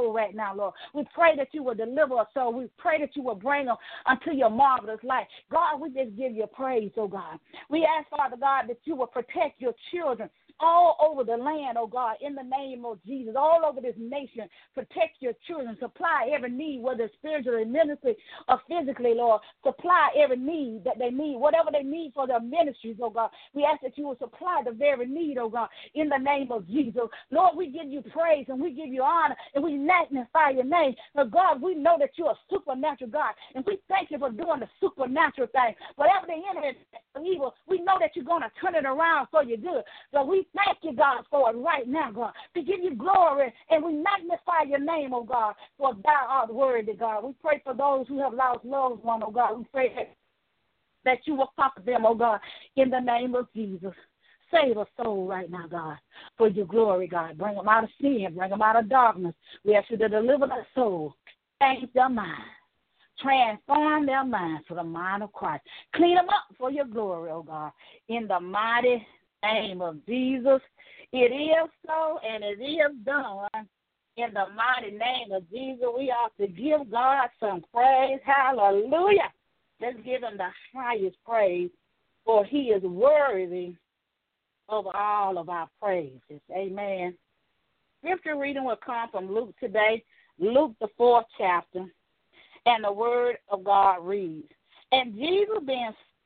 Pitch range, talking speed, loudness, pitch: 225-300 Hz, 195 wpm, -26 LUFS, 260 Hz